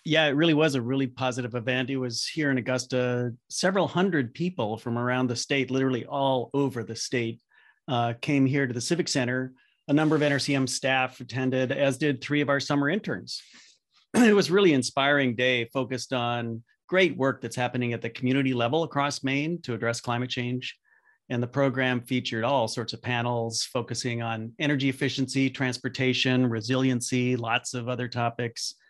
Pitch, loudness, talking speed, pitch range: 130 Hz, -26 LUFS, 175 wpm, 120-140 Hz